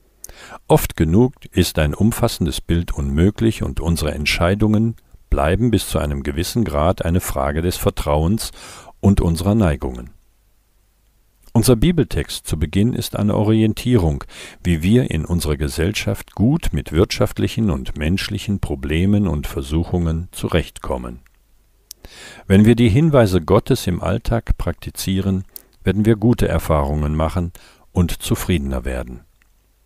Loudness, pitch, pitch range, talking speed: -19 LUFS, 90 Hz, 80-105 Hz, 120 wpm